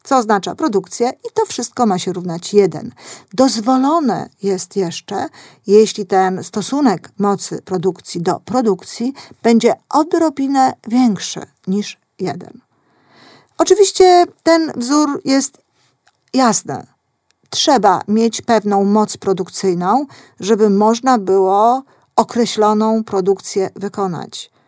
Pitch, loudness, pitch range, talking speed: 220 Hz, -15 LUFS, 195-260 Hz, 100 wpm